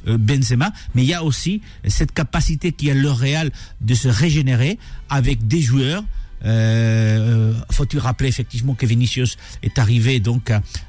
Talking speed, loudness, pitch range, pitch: 145 wpm, -18 LUFS, 115-145 Hz, 125 Hz